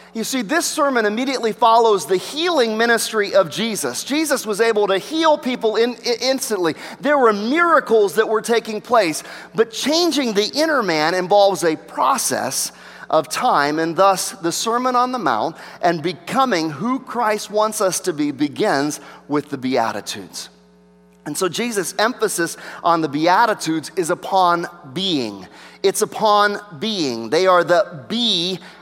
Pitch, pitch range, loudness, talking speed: 210 Hz, 175-240 Hz, -18 LUFS, 150 wpm